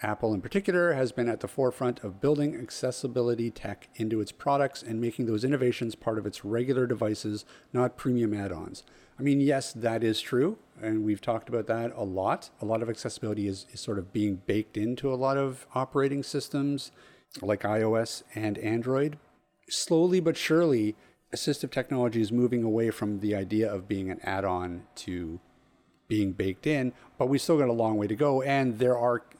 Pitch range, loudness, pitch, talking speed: 105-135 Hz, -29 LUFS, 115 Hz, 190 wpm